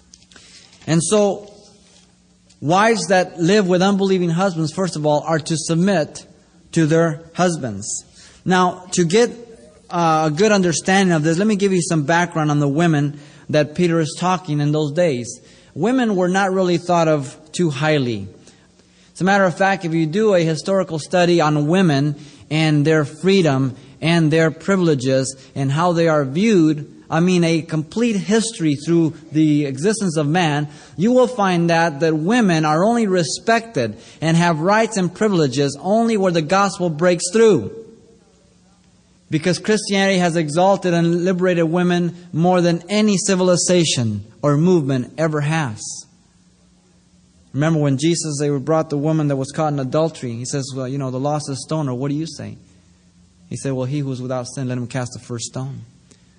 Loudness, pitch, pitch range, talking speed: -18 LUFS, 165 Hz, 145-185 Hz, 170 wpm